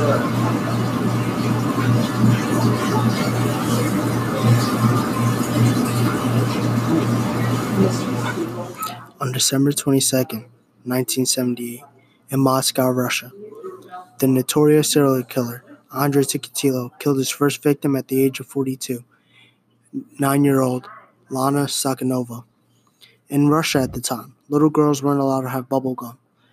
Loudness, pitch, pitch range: -20 LUFS, 130 Hz, 120-140 Hz